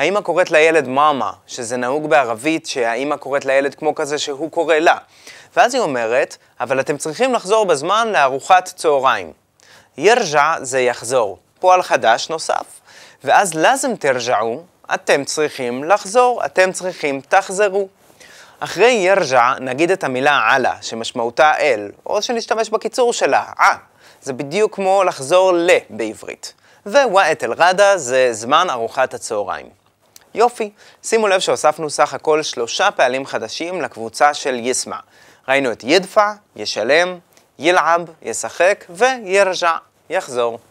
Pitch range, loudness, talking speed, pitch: 135-195 Hz, -16 LUFS, 125 wpm, 160 Hz